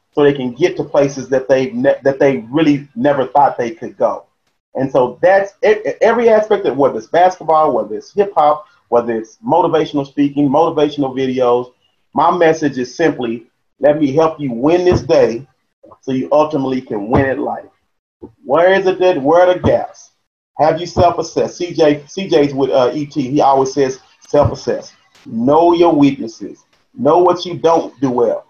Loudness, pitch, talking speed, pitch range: -14 LUFS, 150 Hz, 180 wpm, 135-175 Hz